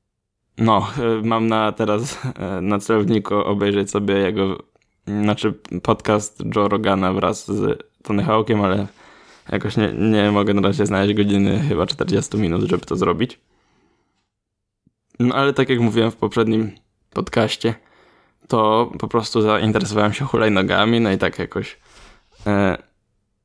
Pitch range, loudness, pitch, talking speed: 100-110 Hz, -19 LUFS, 105 Hz, 130 wpm